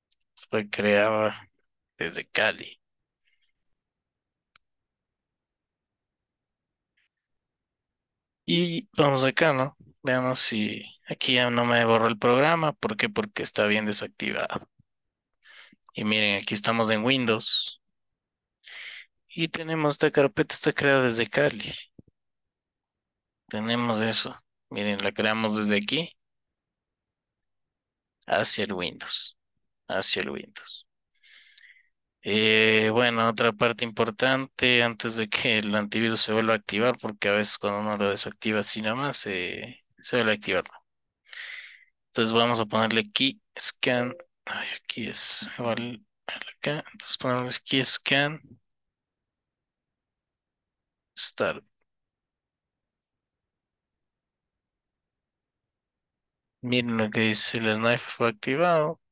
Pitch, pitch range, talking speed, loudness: 115 Hz, 110-130 Hz, 105 wpm, -23 LUFS